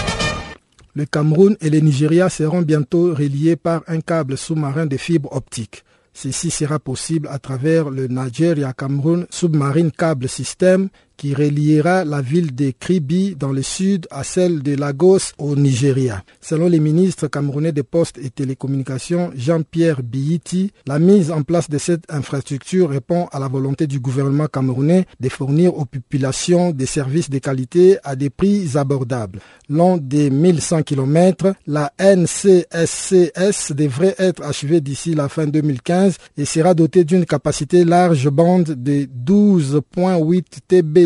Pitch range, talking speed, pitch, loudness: 140-175 Hz, 145 wpm, 155 Hz, -17 LUFS